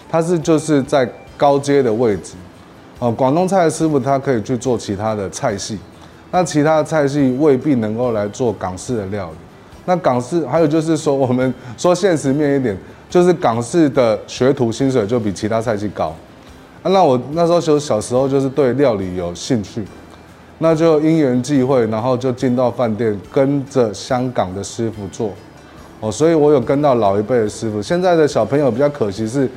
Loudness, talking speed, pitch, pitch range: -16 LUFS, 280 characters per minute, 130 Hz, 105-150 Hz